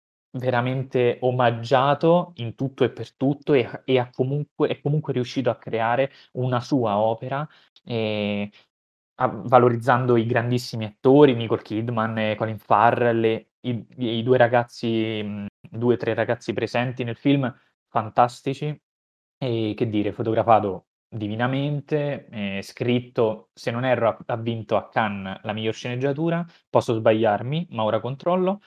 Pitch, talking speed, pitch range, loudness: 120 Hz, 135 wpm, 110-130 Hz, -23 LUFS